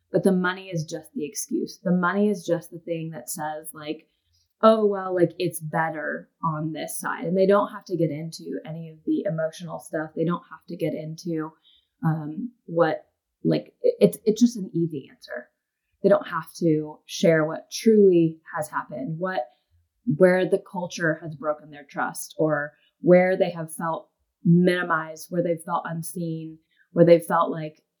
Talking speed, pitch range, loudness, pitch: 180 wpm, 155-185 Hz, -24 LUFS, 165 Hz